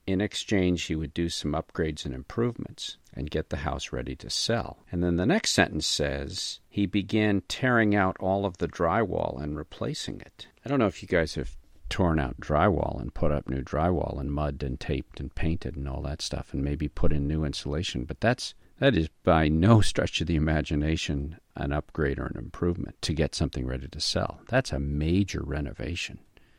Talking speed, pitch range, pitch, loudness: 200 wpm, 70-90 Hz, 80 Hz, -28 LUFS